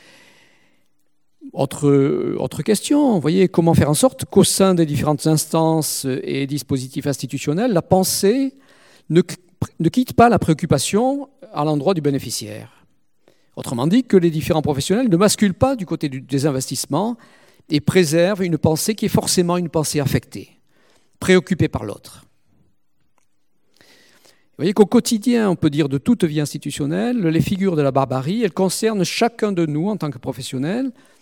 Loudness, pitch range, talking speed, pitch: -18 LUFS, 145-200 Hz, 155 wpm, 165 Hz